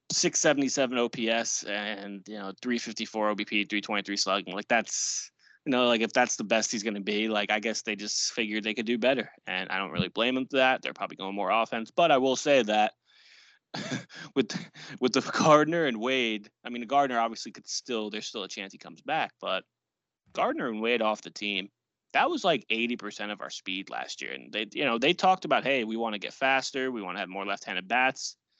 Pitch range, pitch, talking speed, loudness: 105-125 Hz, 115 Hz, 220 wpm, -28 LUFS